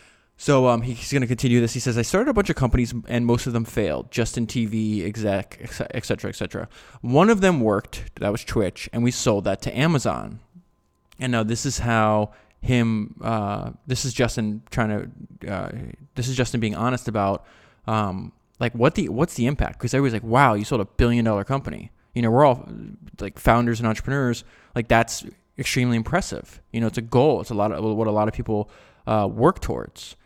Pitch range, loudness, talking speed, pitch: 110-130 Hz, -23 LUFS, 205 wpm, 120 Hz